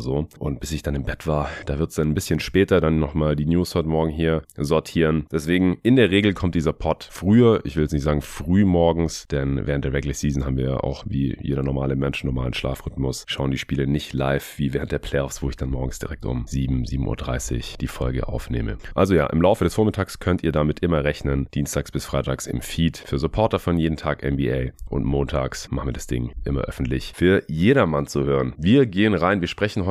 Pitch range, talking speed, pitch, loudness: 70-85 Hz, 225 wpm, 75 Hz, -22 LUFS